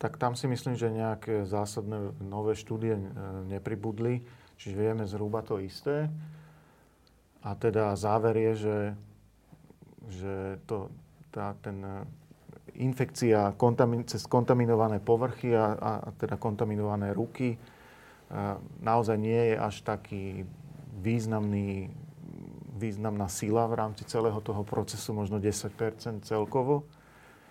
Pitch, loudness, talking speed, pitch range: 110 Hz, -31 LUFS, 110 wpm, 105-120 Hz